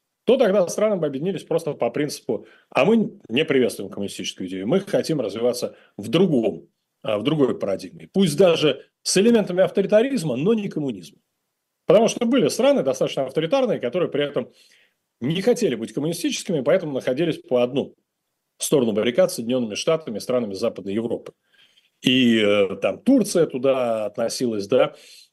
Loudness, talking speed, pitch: -21 LUFS, 145 wpm, 180 Hz